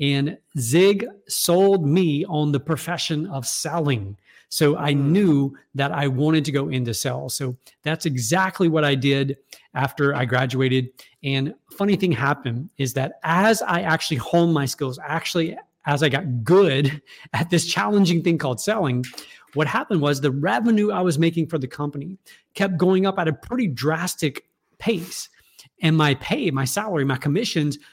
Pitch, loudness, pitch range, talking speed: 150 Hz, -22 LUFS, 140-170 Hz, 165 wpm